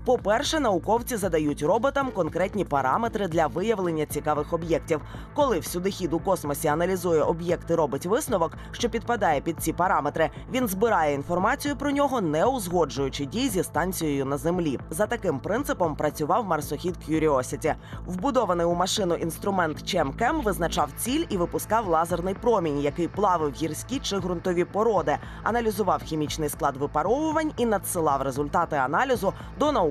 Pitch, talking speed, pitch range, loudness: 175 Hz, 140 wpm, 155-215 Hz, -26 LUFS